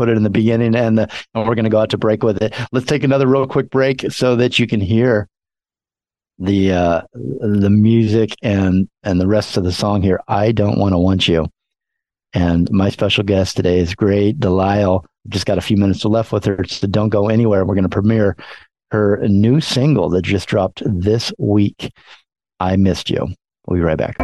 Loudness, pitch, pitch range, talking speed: -16 LUFS, 105 Hz, 95-115 Hz, 210 wpm